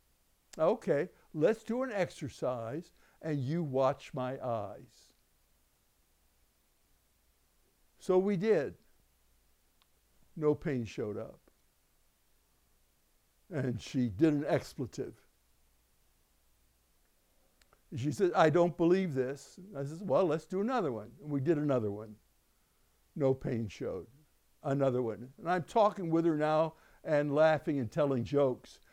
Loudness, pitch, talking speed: -33 LUFS, 135 Hz, 120 wpm